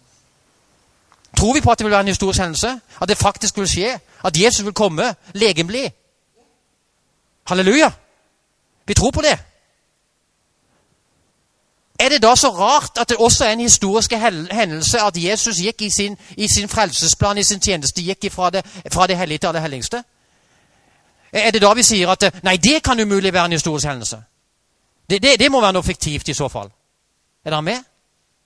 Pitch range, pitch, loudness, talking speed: 175-225 Hz, 200 Hz, -16 LUFS, 175 wpm